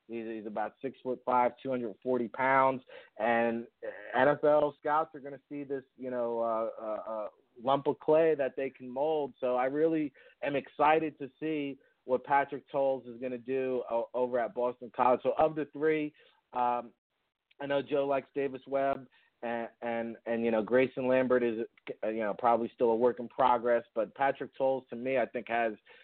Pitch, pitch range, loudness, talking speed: 130 Hz, 120-140 Hz, -31 LUFS, 200 wpm